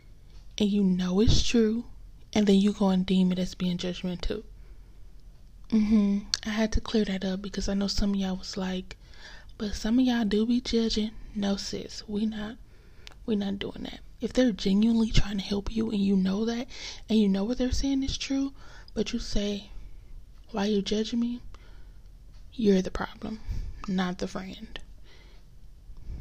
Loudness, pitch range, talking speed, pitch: -28 LUFS, 195-225 Hz, 180 wpm, 210 Hz